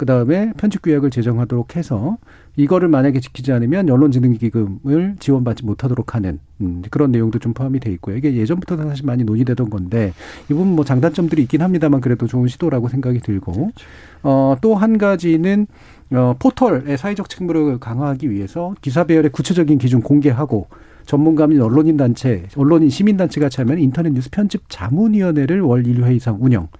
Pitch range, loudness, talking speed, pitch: 120-165 Hz, -16 LUFS, 405 characters per minute, 140 Hz